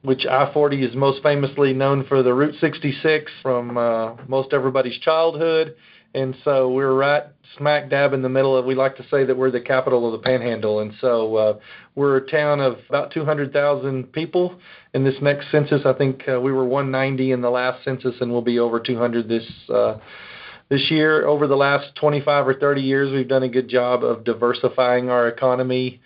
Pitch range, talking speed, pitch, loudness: 125-145 Hz, 195 wpm, 135 Hz, -20 LUFS